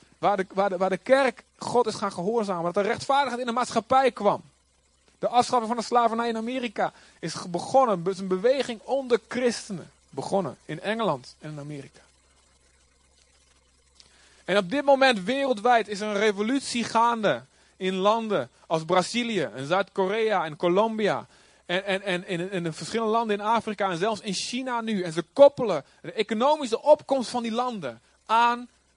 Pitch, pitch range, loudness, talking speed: 210 Hz, 180-240 Hz, -25 LUFS, 170 wpm